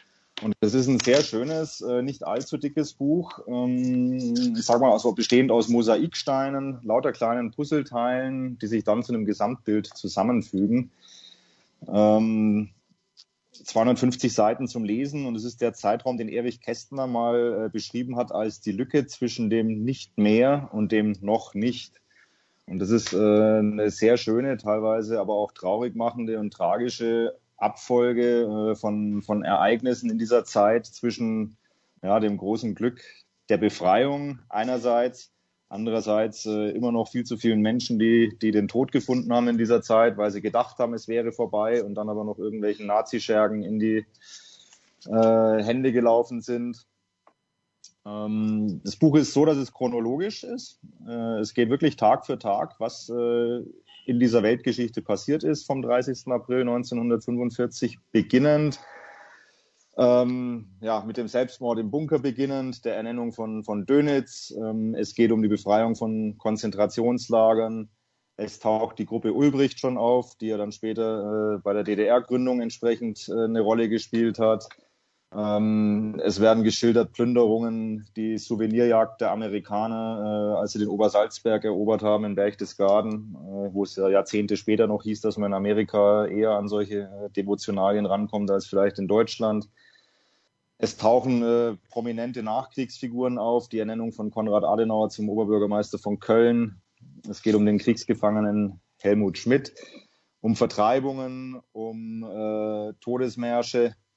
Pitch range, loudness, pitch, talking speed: 105-120 Hz, -24 LUFS, 115 Hz, 145 wpm